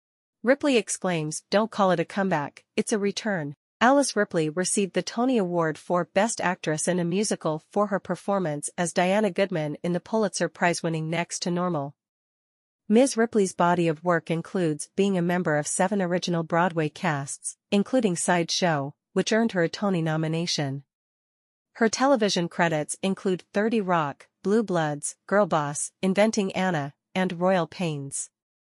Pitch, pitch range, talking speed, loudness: 180 Hz, 165-205 Hz, 150 wpm, -25 LUFS